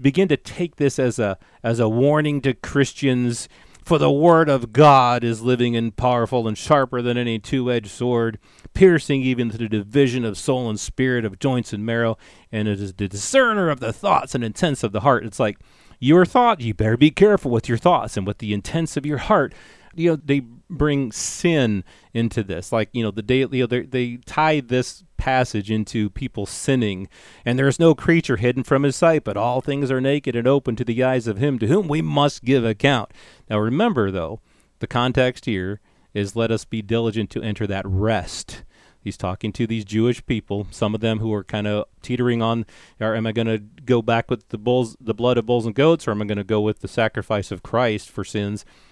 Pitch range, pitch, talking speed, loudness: 110-135 Hz, 120 Hz, 215 wpm, -20 LUFS